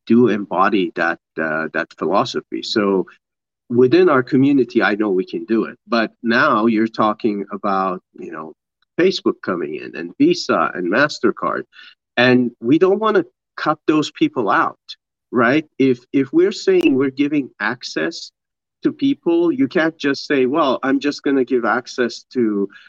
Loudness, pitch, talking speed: -18 LUFS, 150 Hz, 160 wpm